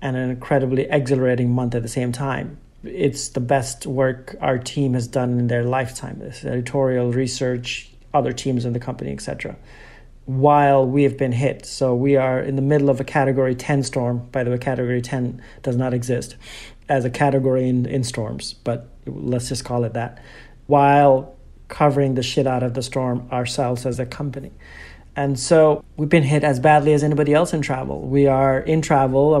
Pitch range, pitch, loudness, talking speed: 125-140 Hz, 130 Hz, -20 LUFS, 190 wpm